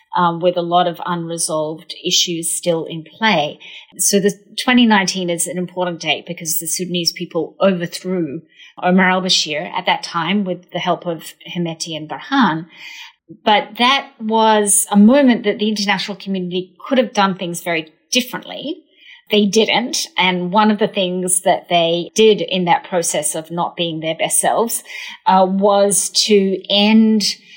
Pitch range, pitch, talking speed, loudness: 170-210 Hz, 185 Hz, 160 wpm, -16 LUFS